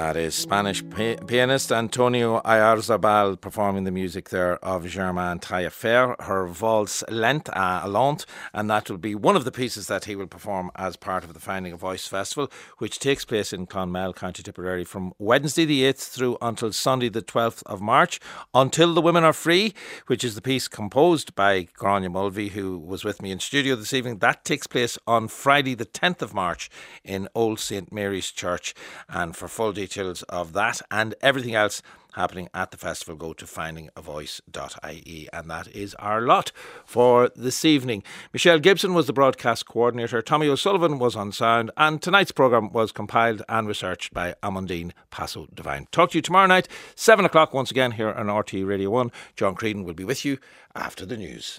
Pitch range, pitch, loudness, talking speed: 95-125 Hz, 105 Hz, -23 LUFS, 190 wpm